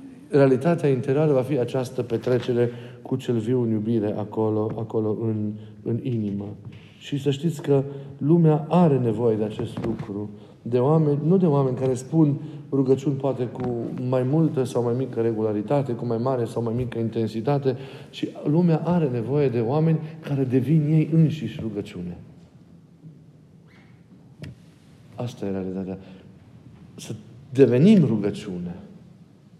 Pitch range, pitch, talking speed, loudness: 115-150 Hz, 130 Hz, 135 wpm, -23 LUFS